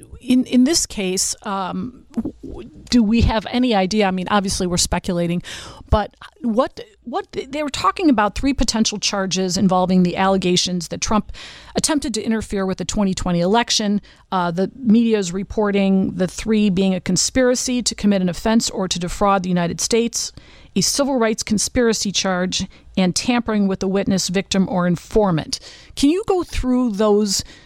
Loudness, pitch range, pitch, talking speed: -19 LUFS, 185-240 Hz, 205 Hz, 165 wpm